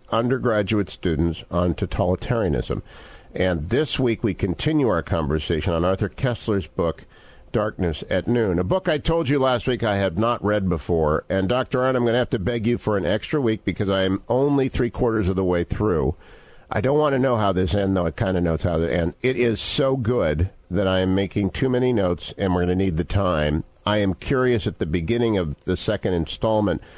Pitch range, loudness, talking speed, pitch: 90-120 Hz, -22 LUFS, 220 wpm, 105 Hz